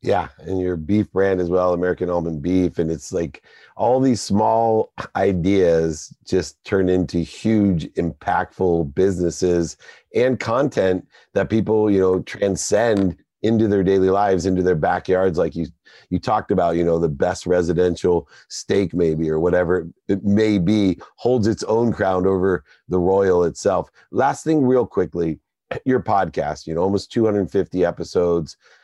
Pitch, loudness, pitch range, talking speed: 95 Hz, -20 LUFS, 85-105 Hz, 150 wpm